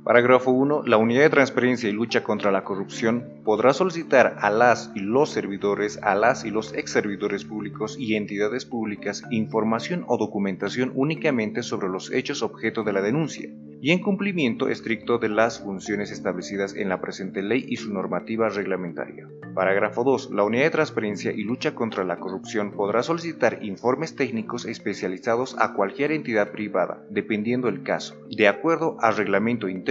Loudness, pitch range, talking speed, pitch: -24 LUFS, 100-125 Hz, 165 wpm, 110 Hz